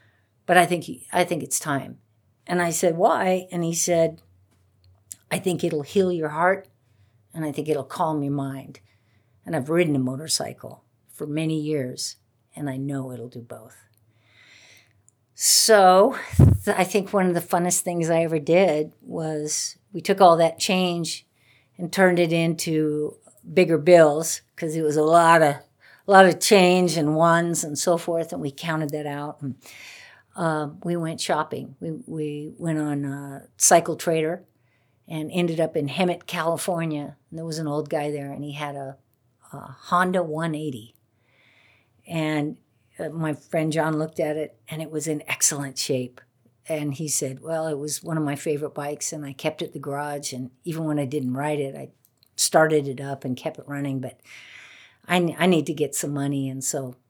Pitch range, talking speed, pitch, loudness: 135-165 Hz, 185 wpm, 155 Hz, -23 LUFS